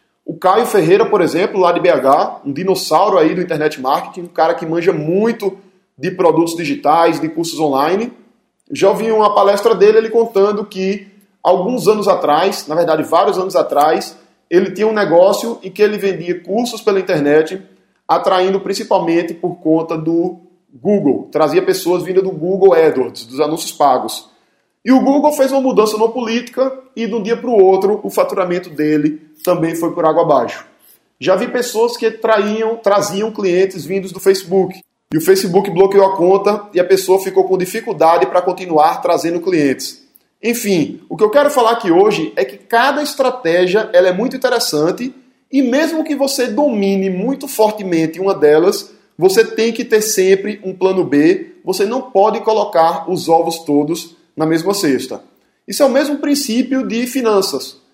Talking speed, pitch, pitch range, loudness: 170 wpm, 195 Hz, 175-230 Hz, -14 LUFS